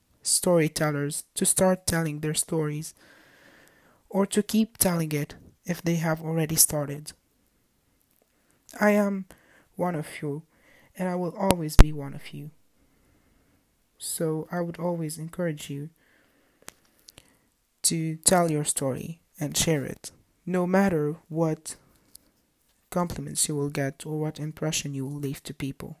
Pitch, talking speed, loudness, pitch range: 160 Hz, 130 wpm, -26 LUFS, 150-175 Hz